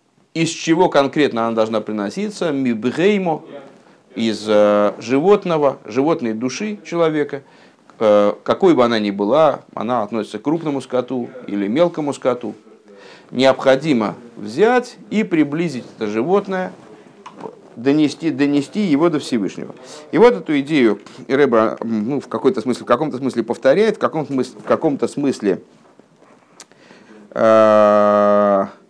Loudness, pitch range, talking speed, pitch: -17 LUFS, 110-165 Hz, 110 wpm, 135 Hz